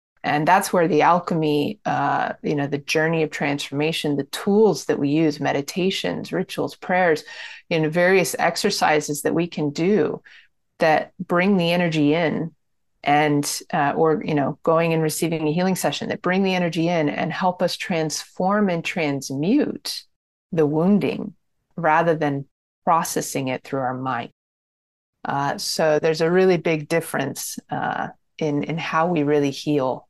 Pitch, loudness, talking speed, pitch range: 160 Hz, -21 LUFS, 155 wpm, 150-180 Hz